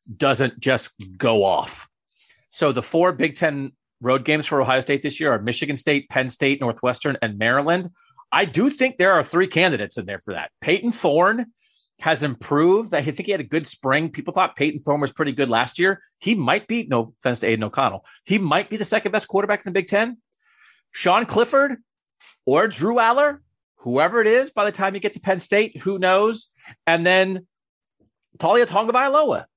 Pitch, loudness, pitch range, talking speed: 175 Hz, -20 LUFS, 135-210 Hz, 195 wpm